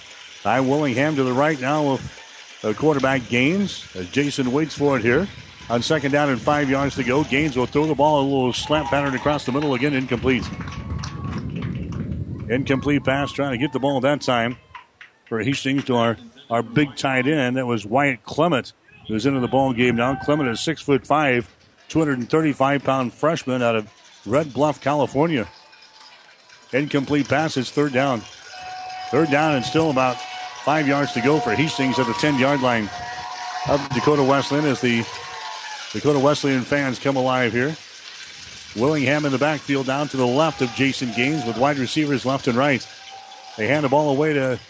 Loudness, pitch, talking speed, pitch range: -21 LUFS, 135 Hz, 175 wpm, 125-145 Hz